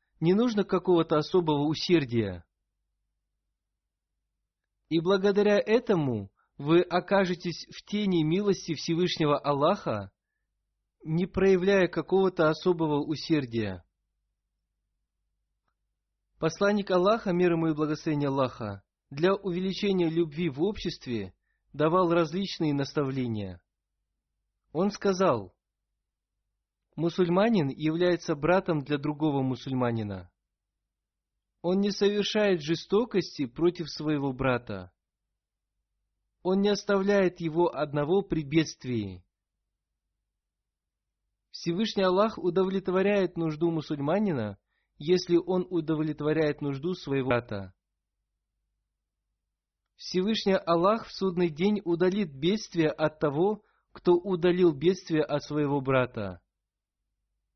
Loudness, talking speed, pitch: -27 LUFS, 85 wpm, 155 Hz